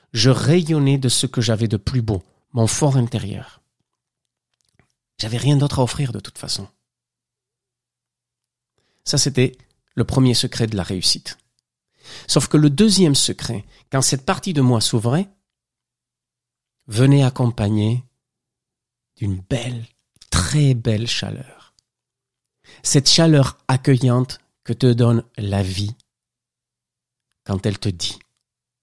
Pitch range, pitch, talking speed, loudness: 115-135 Hz, 125 Hz, 120 wpm, -18 LUFS